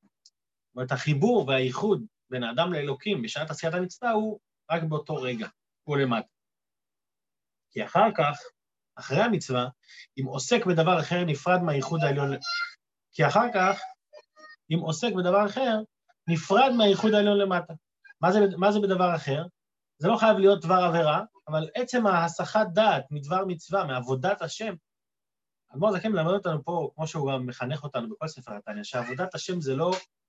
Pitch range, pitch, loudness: 150-205 Hz, 180 Hz, -26 LUFS